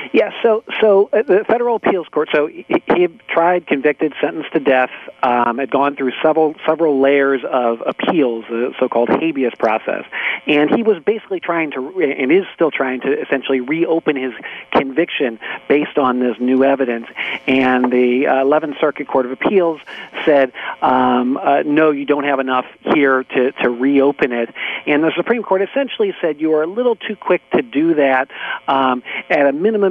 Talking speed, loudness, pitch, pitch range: 180 wpm, -16 LUFS, 145 Hz, 130-175 Hz